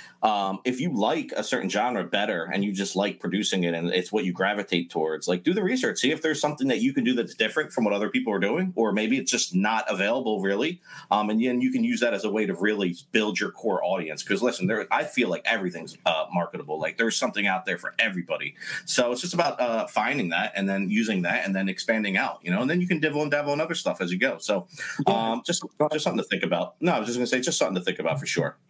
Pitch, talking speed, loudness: 120 Hz, 275 wpm, -26 LUFS